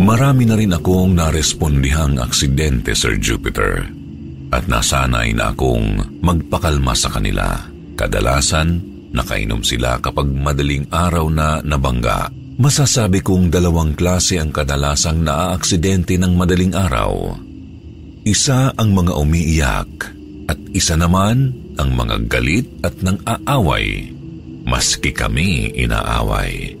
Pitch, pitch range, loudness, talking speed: 85 Hz, 70-95 Hz, -16 LUFS, 110 wpm